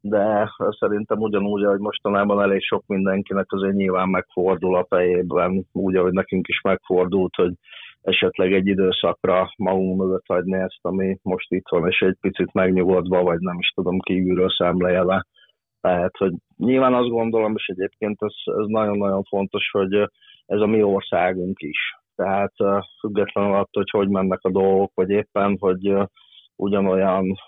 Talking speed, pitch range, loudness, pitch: 150 wpm, 95-100 Hz, -21 LUFS, 95 Hz